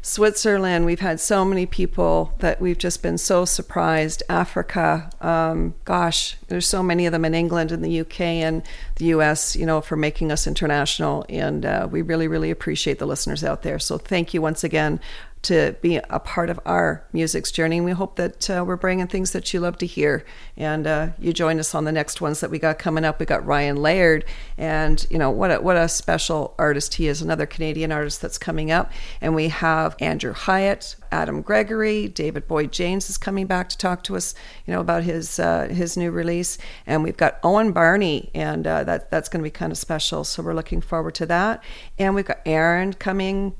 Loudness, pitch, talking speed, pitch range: -22 LUFS, 165 Hz, 215 wpm, 155-180 Hz